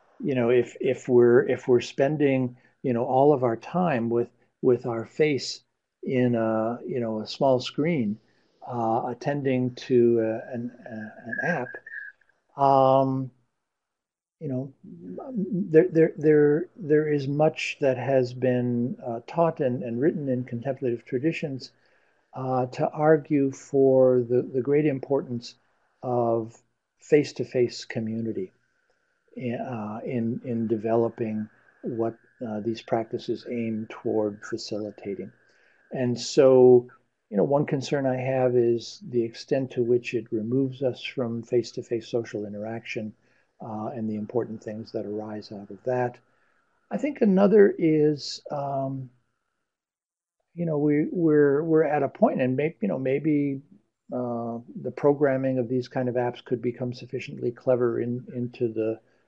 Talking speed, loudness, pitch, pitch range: 145 wpm, -25 LUFS, 125 Hz, 115-140 Hz